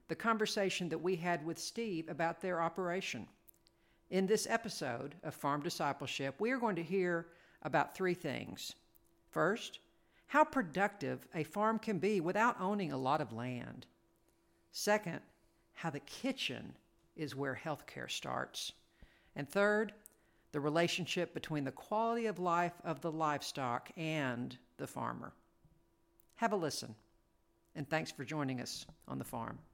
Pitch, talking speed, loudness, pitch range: 170 Hz, 145 wpm, -38 LUFS, 145-200 Hz